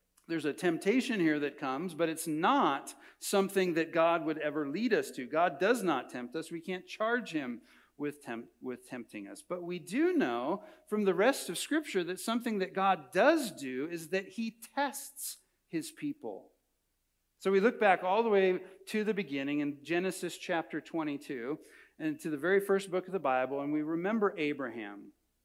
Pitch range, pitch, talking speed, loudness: 155-210 Hz, 180 Hz, 185 wpm, -33 LUFS